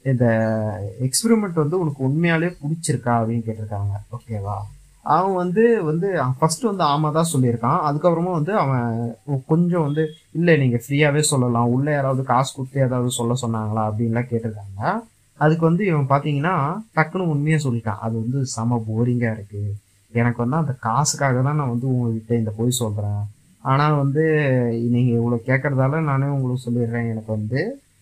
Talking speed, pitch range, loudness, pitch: 145 wpm, 115-150 Hz, -21 LUFS, 130 Hz